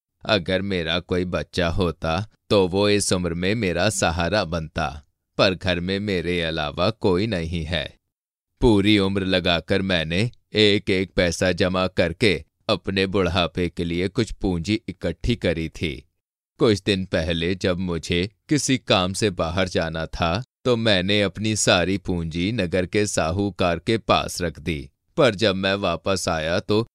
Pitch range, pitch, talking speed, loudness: 85-100 Hz, 95 Hz, 150 wpm, -22 LUFS